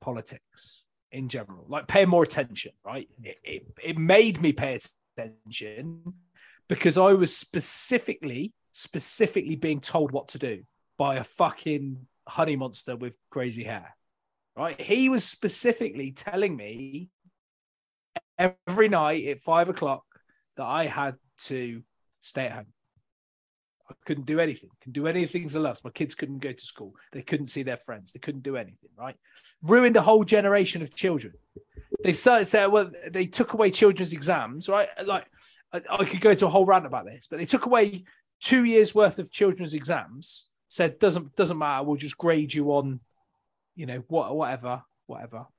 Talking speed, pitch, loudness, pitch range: 165 wpm, 165 Hz, -24 LUFS, 140-195 Hz